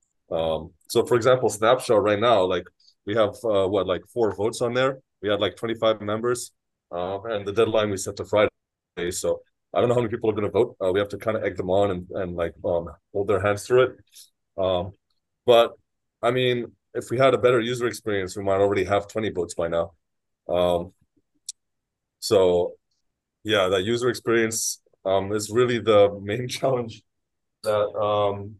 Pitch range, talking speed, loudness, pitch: 100-120 Hz, 195 wpm, -24 LUFS, 105 Hz